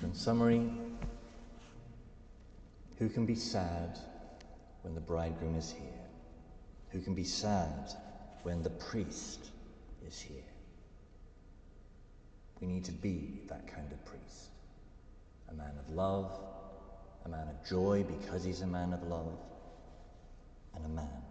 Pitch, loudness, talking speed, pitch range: 90 Hz, -39 LUFS, 125 wpm, 80-100 Hz